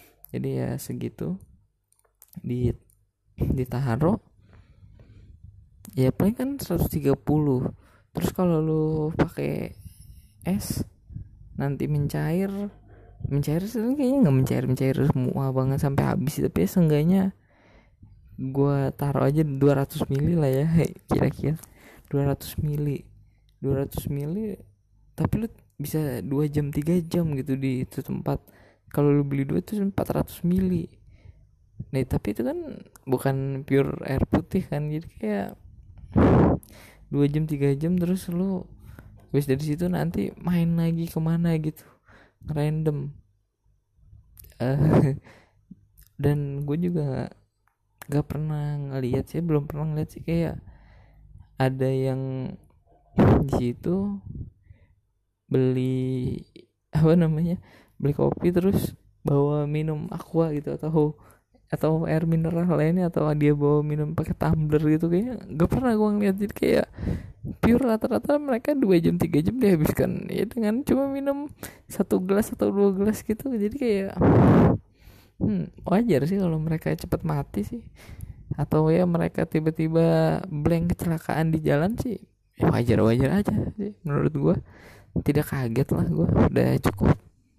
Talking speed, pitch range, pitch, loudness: 125 wpm, 120-170 Hz, 145 Hz, -25 LUFS